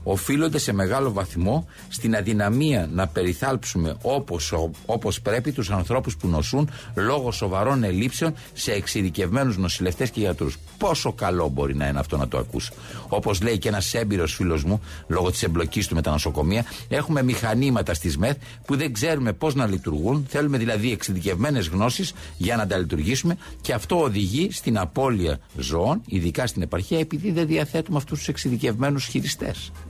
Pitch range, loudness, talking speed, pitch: 90-135 Hz, -24 LUFS, 160 wpm, 105 Hz